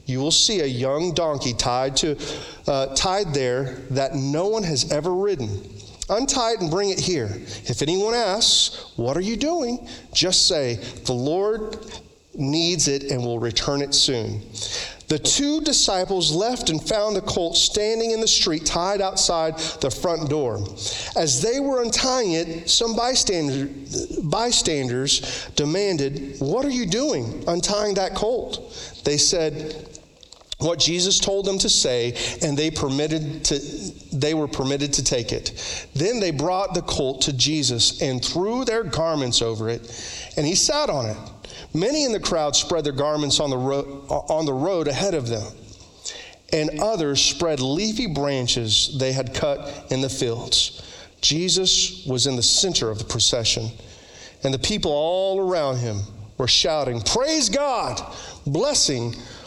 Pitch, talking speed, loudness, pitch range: 150 Hz, 155 wpm, -21 LUFS, 130-190 Hz